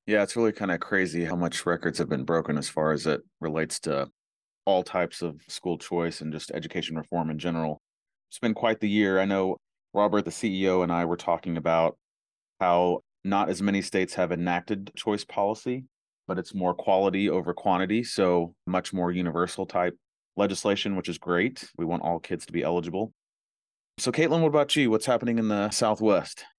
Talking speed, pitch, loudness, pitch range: 190 wpm, 90 Hz, -27 LUFS, 85-105 Hz